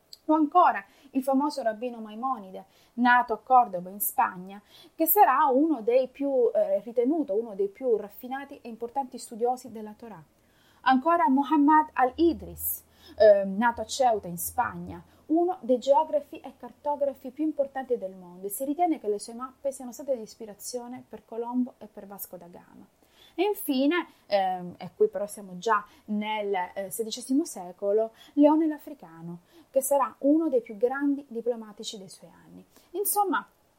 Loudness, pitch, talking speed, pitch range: -26 LUFS, 245 Hz, 160 wpm, 210-285 Hz